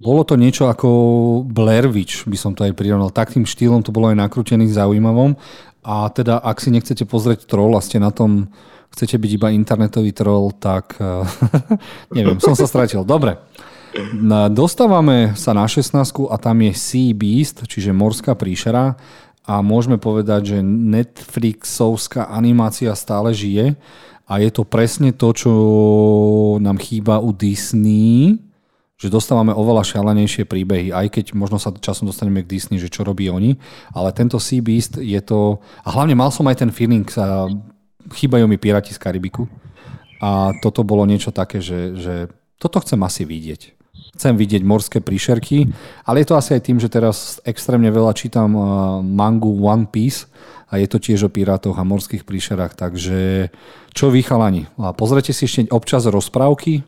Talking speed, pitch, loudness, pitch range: 160 wpm, 110 Hz, -16 LUFS, 100-120 Hz